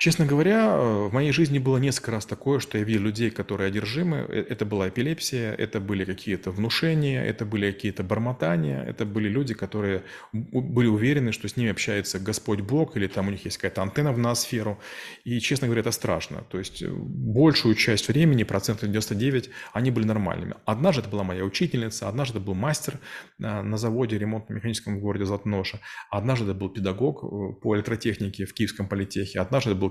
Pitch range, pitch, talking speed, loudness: 100-125 Hz, 110 Hz, 175 wpm, -26 LUFS